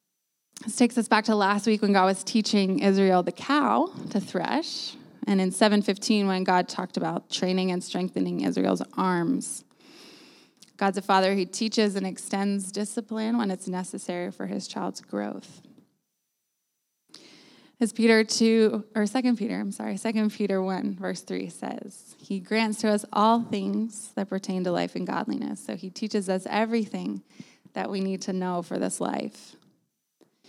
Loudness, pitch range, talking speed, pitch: -26 LUFS, 185-220 Hz, 165 wpm, 200 Hz